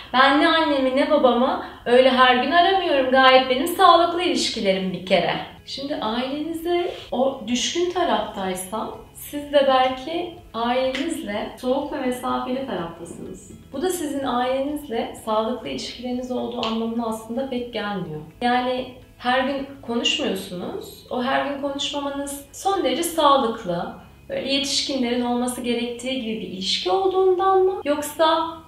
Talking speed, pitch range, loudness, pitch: 125 wpm, 235-290 Hz, -21 LUFS, 260 Hz